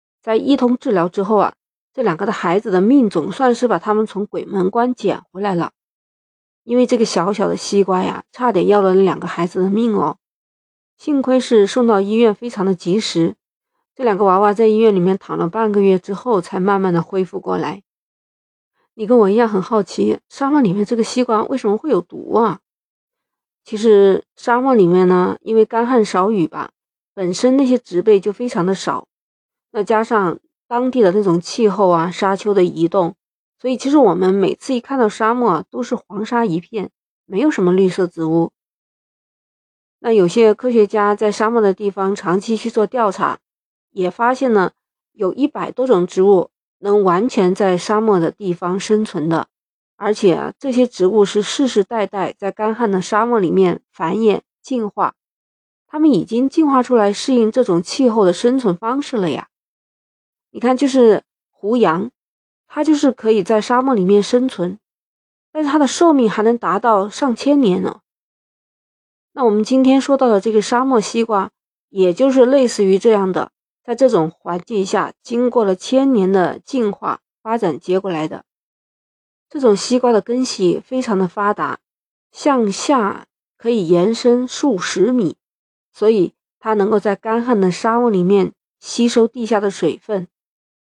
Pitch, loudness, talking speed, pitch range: 215 Hz, -16 LUFS, 250 characters per minute, 190-245 Hz